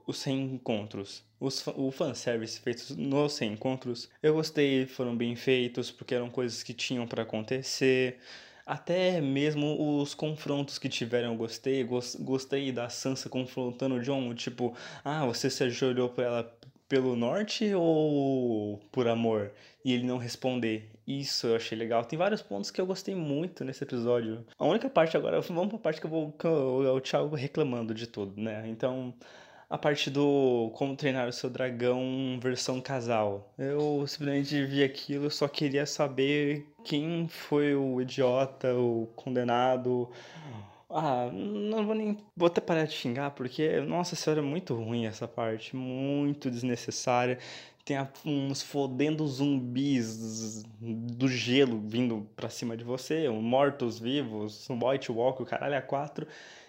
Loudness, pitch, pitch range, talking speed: -31 LUFS, 130 Hz, 120-145 Hz, 155 wpm